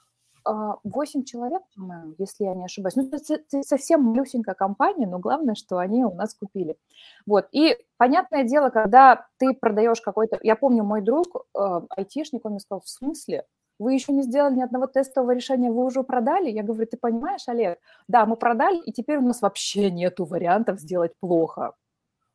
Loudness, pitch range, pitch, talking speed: -23 LUFS, 205-270 Hz, 240 Hz, 170 wpm